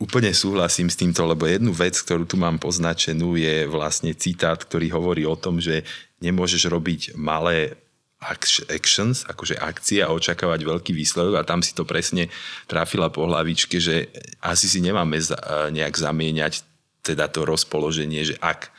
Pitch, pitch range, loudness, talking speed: 85 Hz, 80-85 Hz, -22 LUFS, 155 wpm